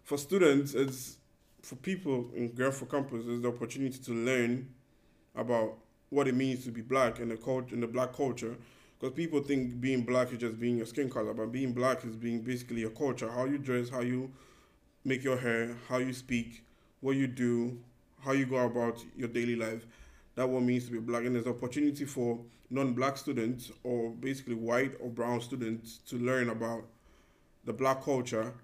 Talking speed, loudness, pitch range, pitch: 195 wpm, -33 LUFS, 120-130 Hz, 125 Hz